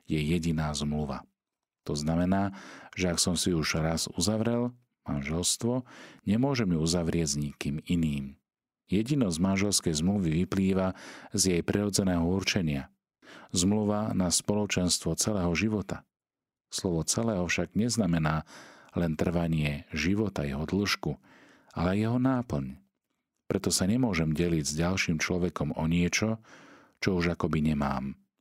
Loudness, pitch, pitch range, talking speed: -29 LUFS, 85 Hz, 80-100 Hz, 120 wpm